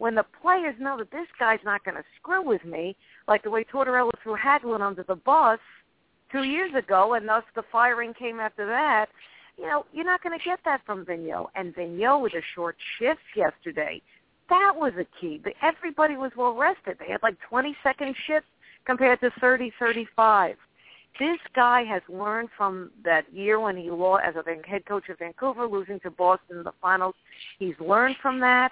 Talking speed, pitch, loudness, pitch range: 190 wpm, 230 Hz, -25 LUFS, 195-270 Hz